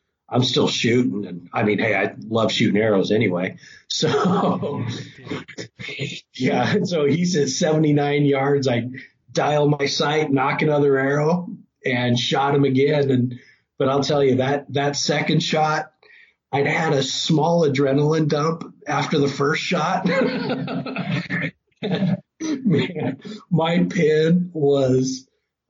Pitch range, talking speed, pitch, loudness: 140-165 Hz, 125 wpm, 150 Hz, -20 LUFS